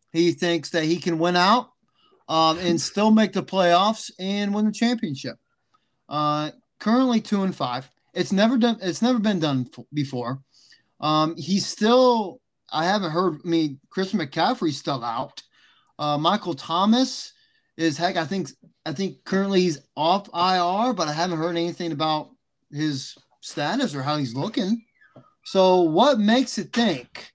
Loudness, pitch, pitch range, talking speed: -23 LUFS, 180 Hz, 155-215 Hz, 160 wpm